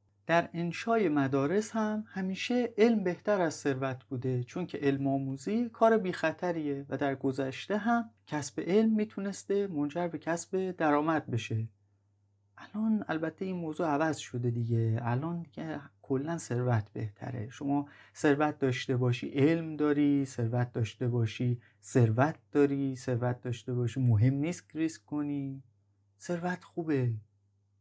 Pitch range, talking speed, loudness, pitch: 125-170 Hz, 130 wpm, -31 LUFS, 140 Hz